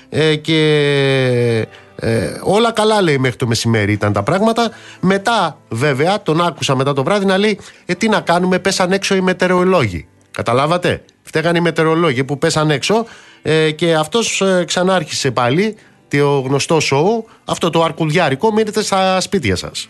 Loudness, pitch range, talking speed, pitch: -15 LUFS, 140-195 Hz, 155 wpm, 165 Hz